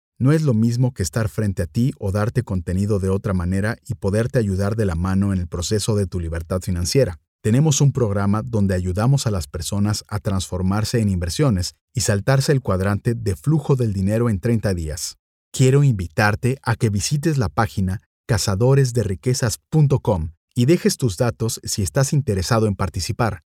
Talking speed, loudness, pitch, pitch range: 175 wpm, -20 LUFS, 105 Hz, 95-125 Hz